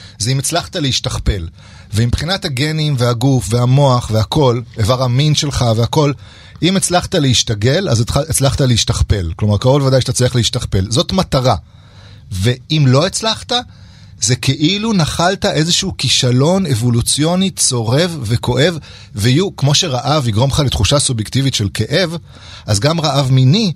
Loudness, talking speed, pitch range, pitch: -14 LUFS, 130 wpm, 115-150 Hz, 130 Hz